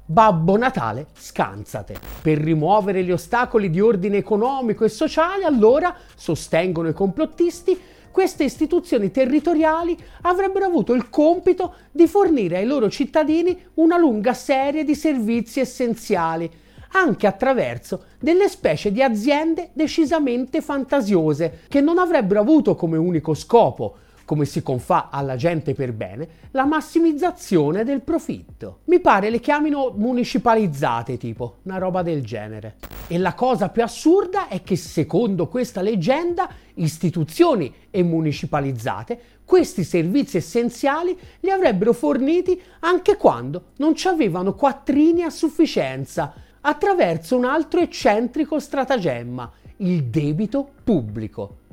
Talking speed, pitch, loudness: 120 wpm, 240 Hz, -20 LUFS